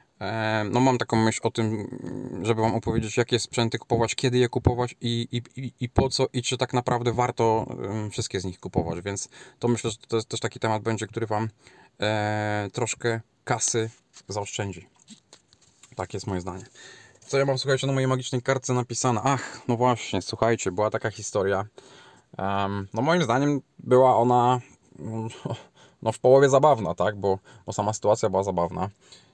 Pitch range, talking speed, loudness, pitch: 105-125 Hz, 170 wpm, -25 LUFS, 115 Hz